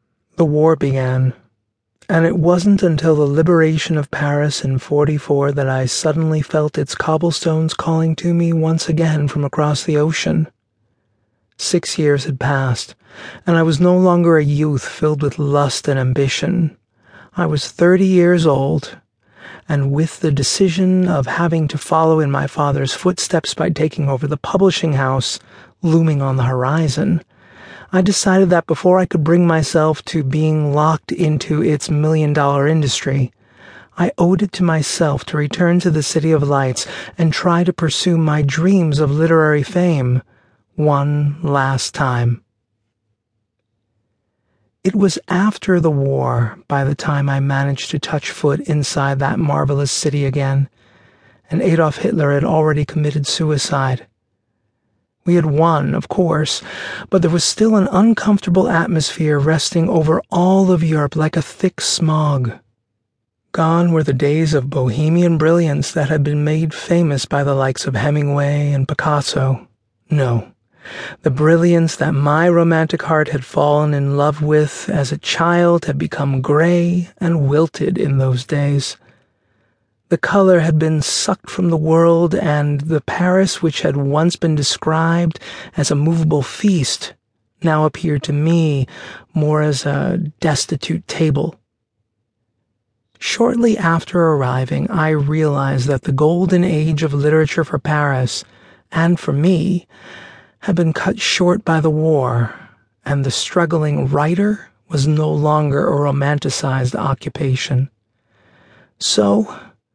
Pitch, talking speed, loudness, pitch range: 150 Hz, 140 wpm, -16 LUFS, 140-165 Hz